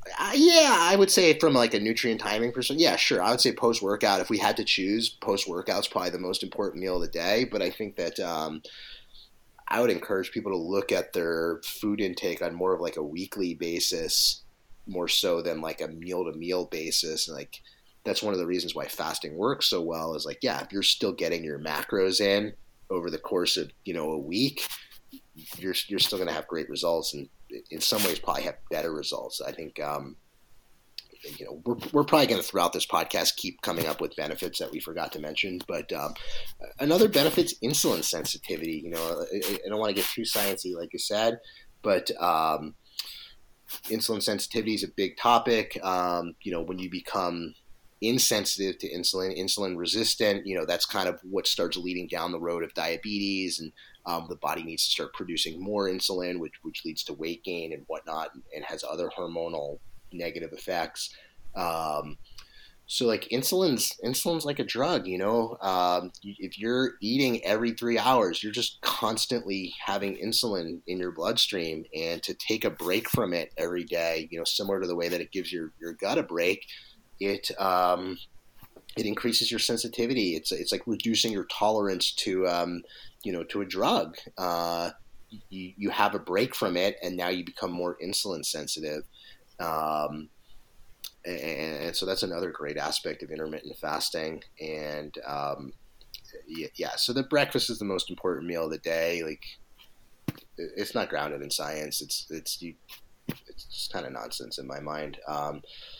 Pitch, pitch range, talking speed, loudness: 90 Hz, 85-110 Hz, 190 wpm, -28 LUFS